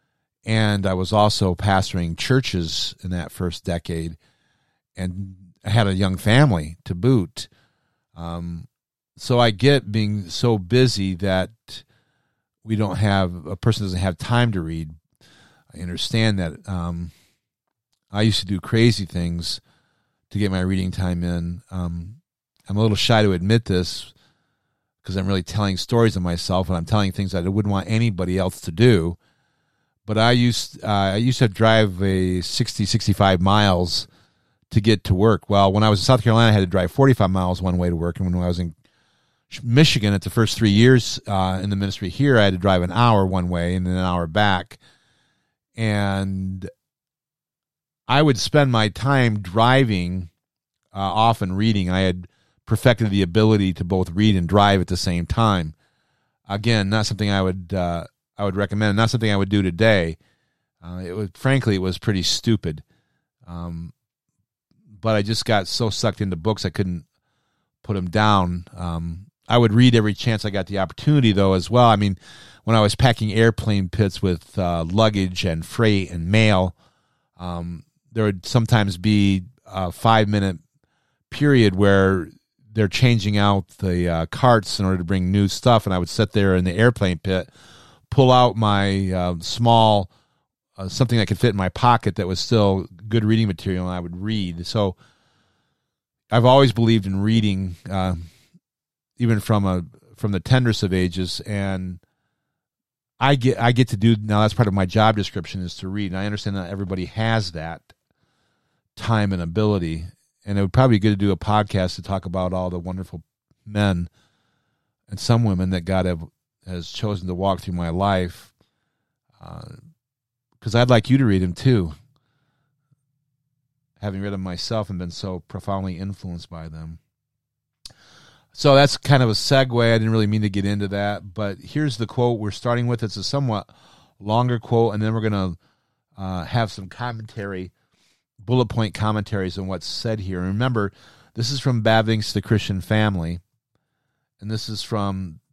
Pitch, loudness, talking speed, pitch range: 100 Hz, -20 LUFS, 180 wpm, 95-115 Hz